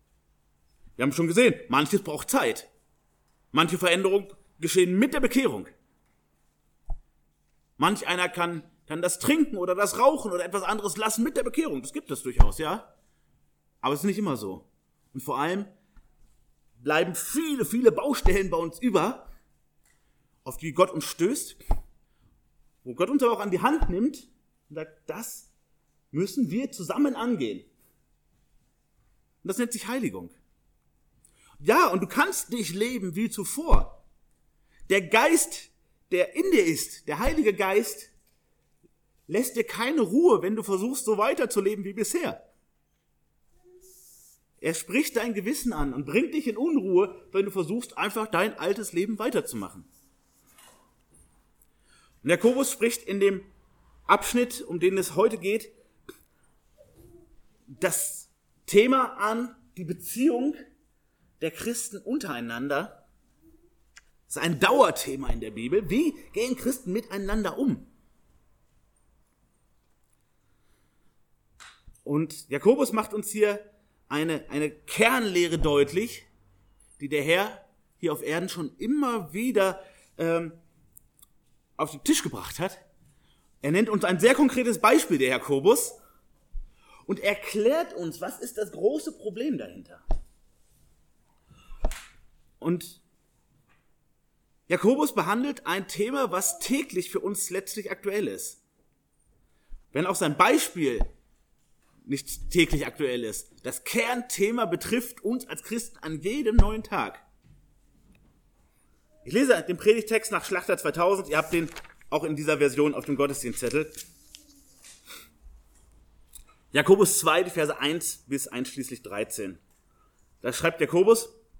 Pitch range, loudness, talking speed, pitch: 160-240 Hz, -26 LUFS, 125 wpm, 200 Hz